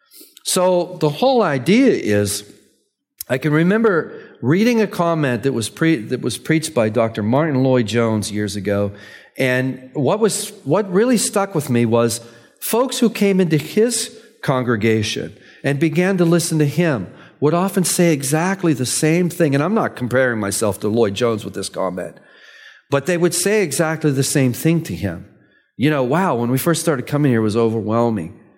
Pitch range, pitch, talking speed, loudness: 120-180 Hz, 150 Hz, 180 wpm, -18 LUFS